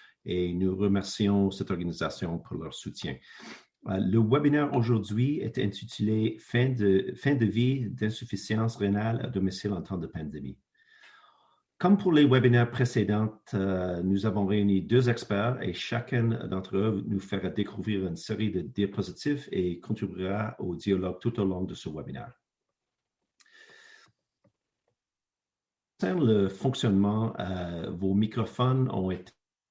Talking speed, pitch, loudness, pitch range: 135 wpm, 105 Hz, -28 LUFS, 95-120 Hz